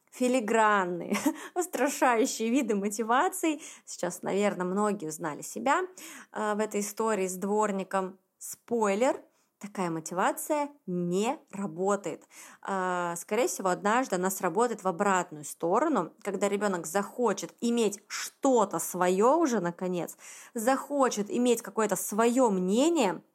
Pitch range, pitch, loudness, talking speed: 190-250 Hz, 210 Hz, -29 LUFS, 105 wpm